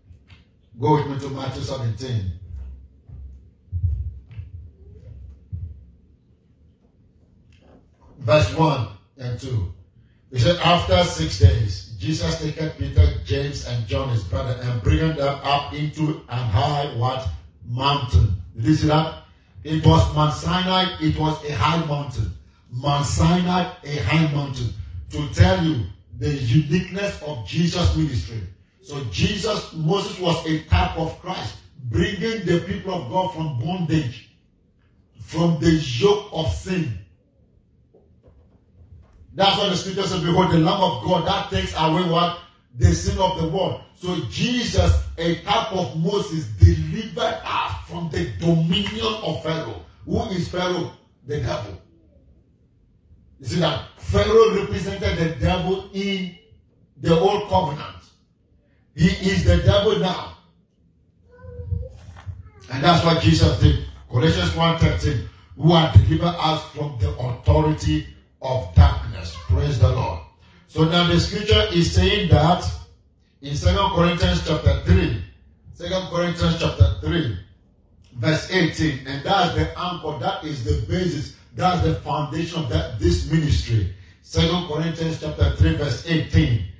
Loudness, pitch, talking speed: -21 LUFS, 125 Hz, 130 wpm